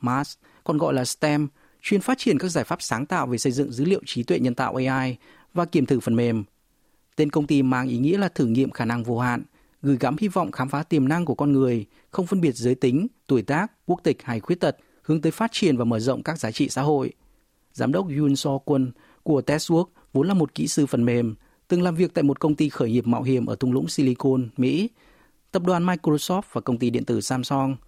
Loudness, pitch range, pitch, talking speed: -23 LUFS, 125-165 Hz, 140 Hz, 250 wpm